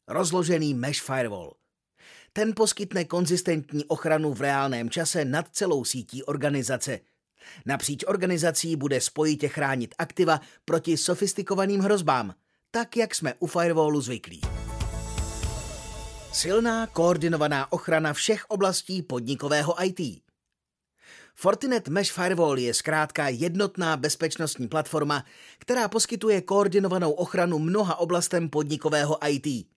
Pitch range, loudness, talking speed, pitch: 140-185 Hz, -26 LUFS, 105 wpm, 160 Hz